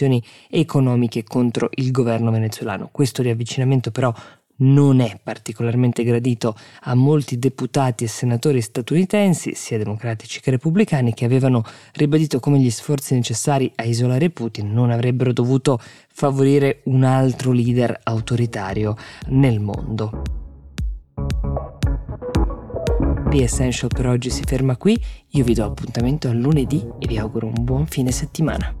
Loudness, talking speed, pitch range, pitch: -20 LUFS, 130 wpm, 115-135 Hz, 125 Hz